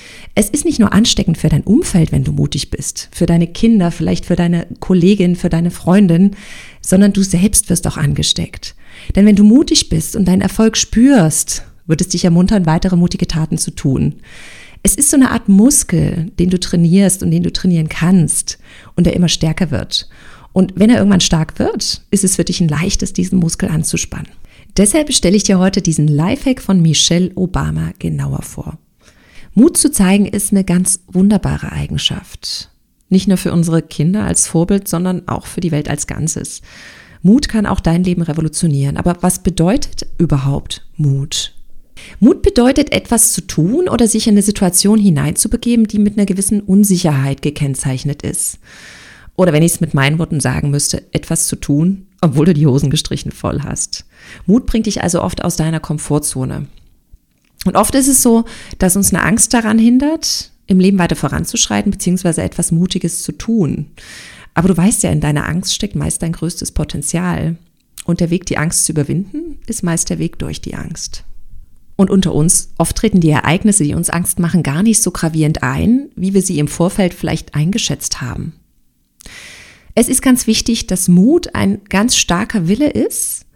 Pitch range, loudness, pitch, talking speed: 160-205 Hz, -13 LUFS, 180 Hz, 180 wpm